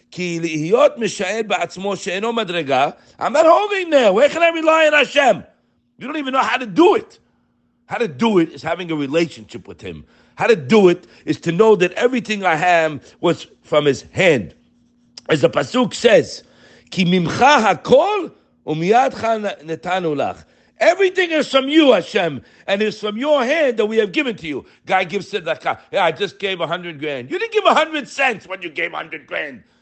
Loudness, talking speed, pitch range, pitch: -17 LUFS, 165 wpm, 170-275 Hz, 205 Hz